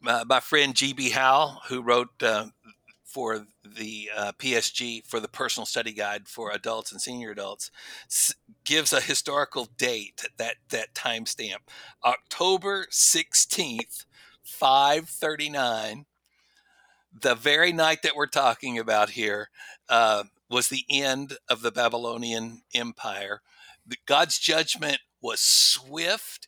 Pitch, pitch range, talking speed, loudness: 125 Hz, 110-140 Hz, 125 wpm, -24 LUFS